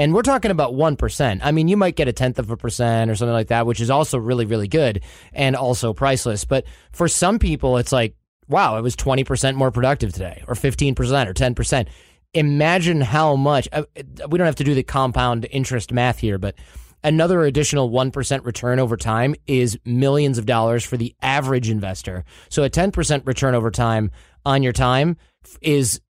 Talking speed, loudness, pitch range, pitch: 190 wpm, -19 LUFS, 120-145 Hz, 130 Hz